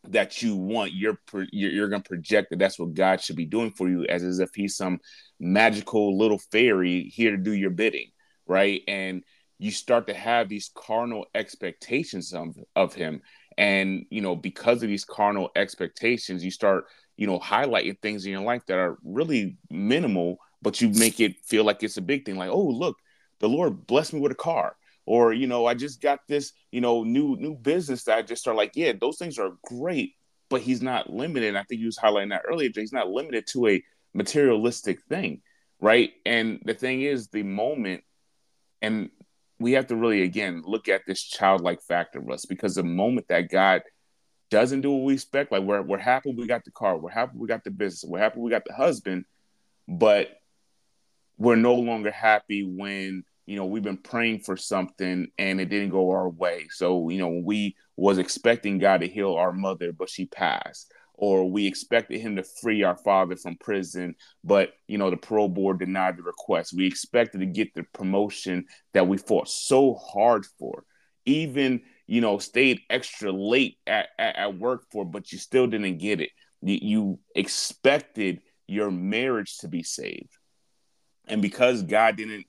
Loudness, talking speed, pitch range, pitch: -25 LUFS, 195 wpm, 95-120 Hz, 105 Hz